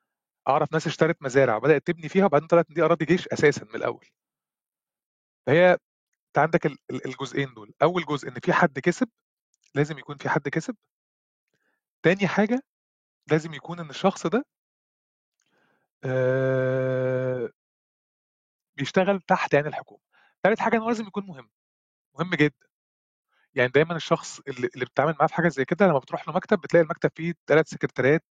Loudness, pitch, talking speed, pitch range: -24 LUFS, 160 Hz, 150 wpm, 135-175 Hz